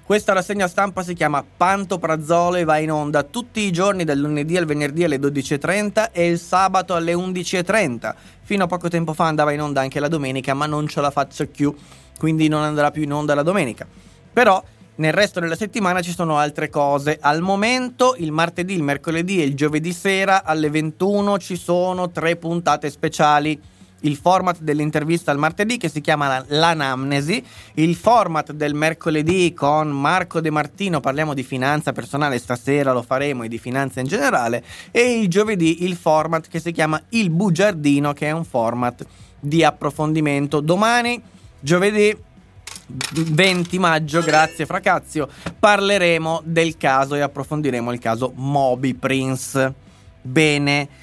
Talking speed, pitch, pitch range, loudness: 160 wpm, 155 Hz, 145-180 Hz, -19 LUFS